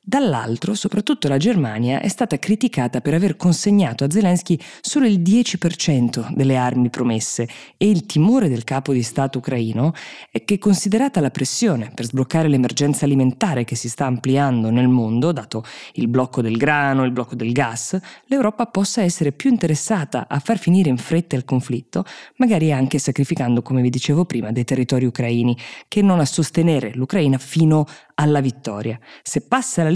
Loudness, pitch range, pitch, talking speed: -19 LUFS, 125-185 Hz, 145 Hz, 165 wpm